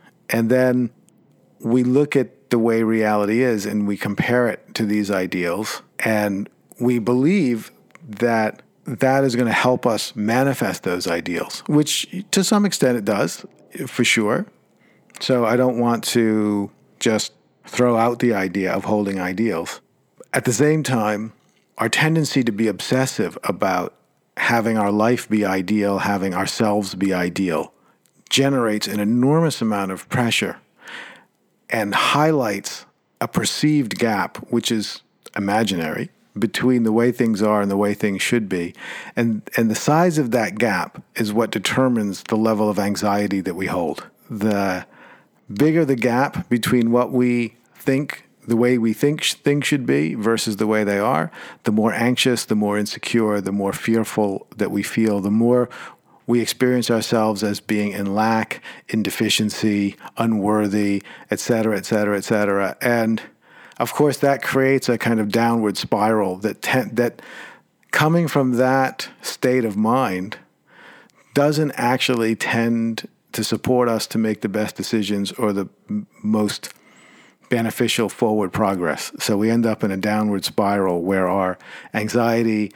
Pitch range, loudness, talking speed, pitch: 105-125 Hz, -20 LUFS, 150 wpm, 115 Hz